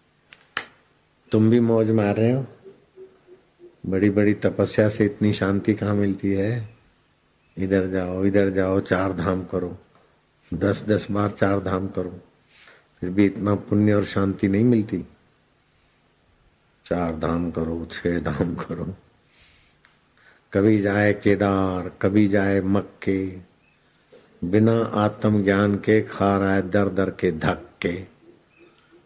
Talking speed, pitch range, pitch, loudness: 120 wpm, 95-105 Hz, 100 Hz, -22 LUFS